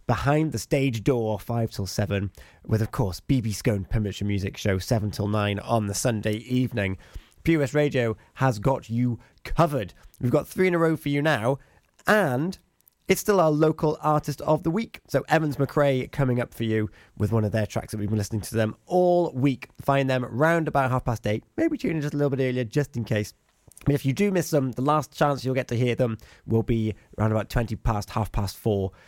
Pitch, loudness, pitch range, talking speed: 125 Hz, -25 LUFS, 110-145 Hz, 225 wpm